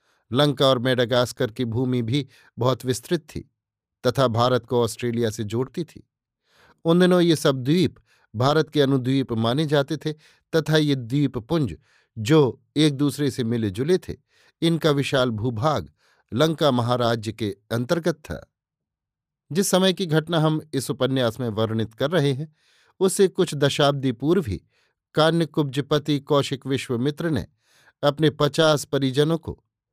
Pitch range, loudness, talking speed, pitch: 125-155 Hz, -22 LUFS, 140 wpm, 140 Hz